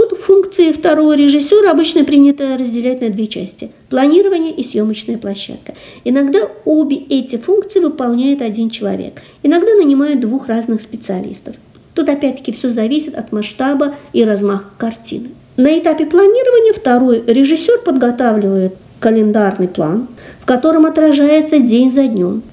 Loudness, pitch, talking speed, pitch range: -13 LUFS, 270 Hz, 130 wpm, 230-315 Hz